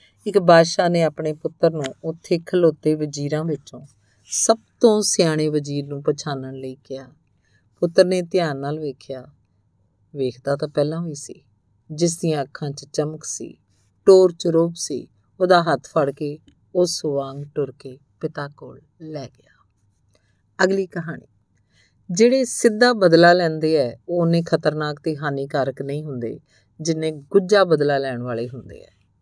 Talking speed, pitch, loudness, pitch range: 145 wpm, 150 Hz, -20 LUFS, 130-170 Hz